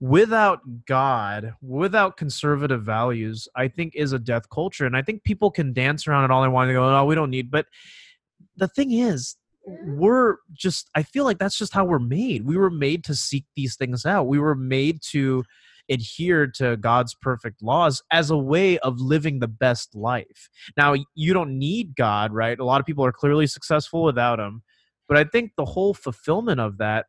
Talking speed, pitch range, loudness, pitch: 200 wpm, 125-170 Hz, -22 LUFS, 145 Hz